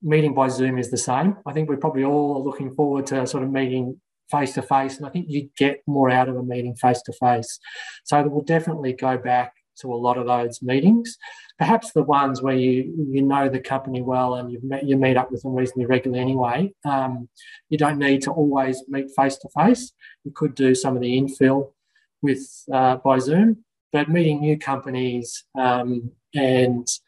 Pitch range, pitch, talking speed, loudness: 130-145 Hz, 135 Hz, 205 wpm, -22 LUFS